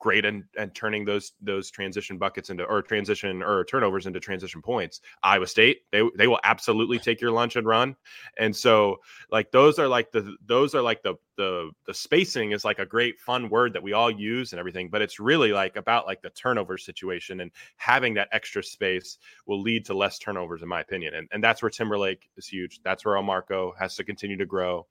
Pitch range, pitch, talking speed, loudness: 95-110 Hz, 100 Hz, 220 wpm, -25 LUFS